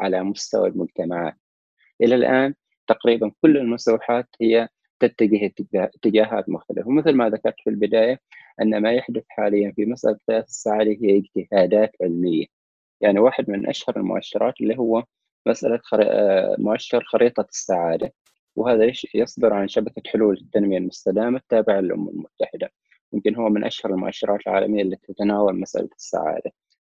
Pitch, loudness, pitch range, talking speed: 105 Hz, -21 LUFS, 100-115 Hz, 130 wpm